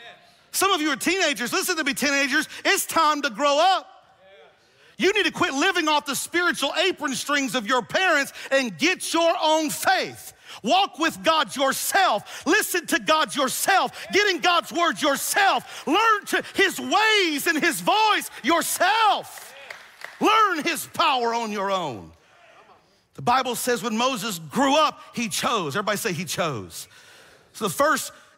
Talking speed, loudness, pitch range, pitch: 160 wpm, -22 LUFS, 270-360 Hz, 310 Hz